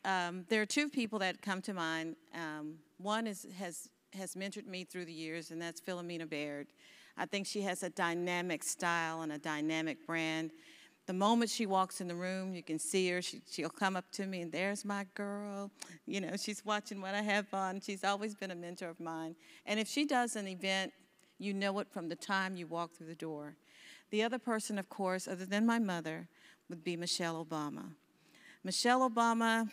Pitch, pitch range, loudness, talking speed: 185 Hz, 170-205 Hz, -37 LUFS, 205 wpm